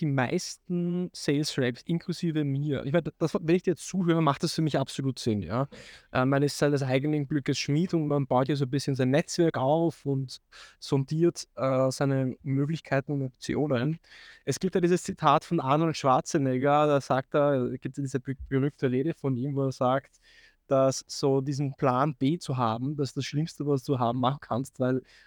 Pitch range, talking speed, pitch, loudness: 135-155 Hz, 200 wpm, 140 Hz, -28 LUFS